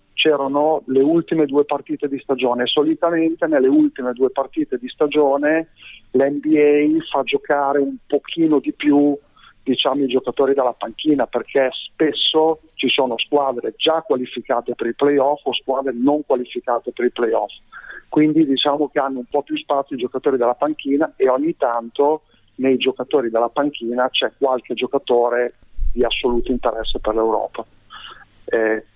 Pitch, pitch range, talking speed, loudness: 140 Hz, 125-150 Hz, 150 wpm, -19 LUFS